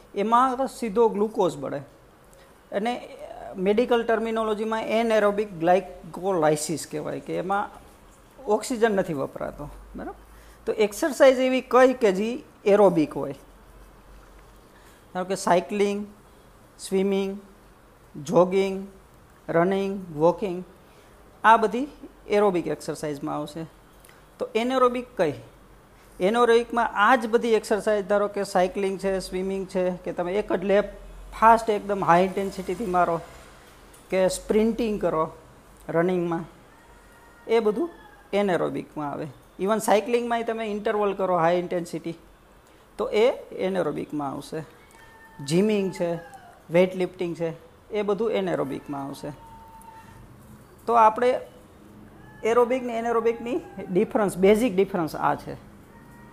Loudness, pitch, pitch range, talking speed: -24 LUFS, 200 Hz, 175-225 Hz, 105 wpm